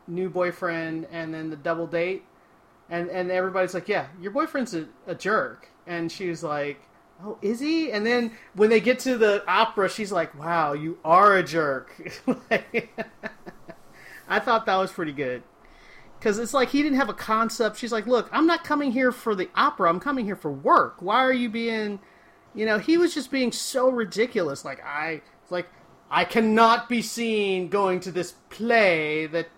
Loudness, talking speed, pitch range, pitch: -24 LUFS, 190 wpm, 175-235 Hz, 205 Hz